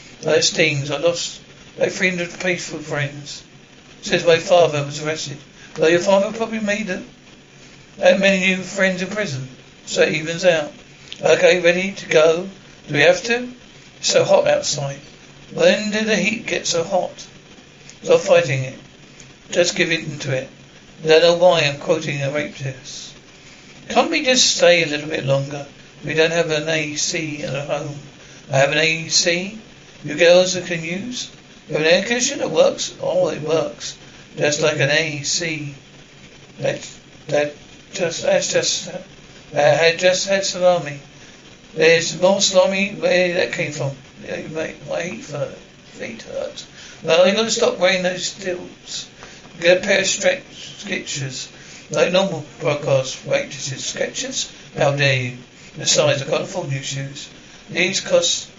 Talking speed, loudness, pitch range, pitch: 165 wpm, -18 LUFS, 145-190 Hz, 170 Hz